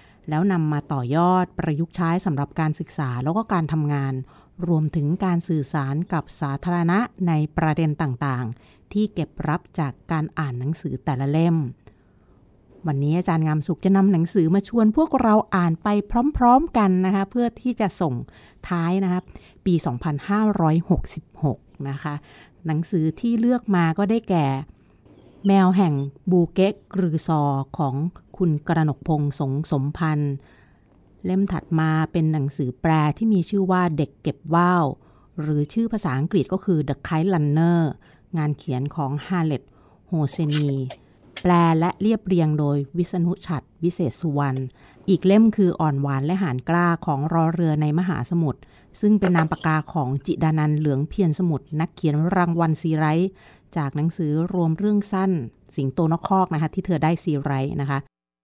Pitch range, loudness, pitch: 145-180 Hz, -22 LUFS, 160 Hz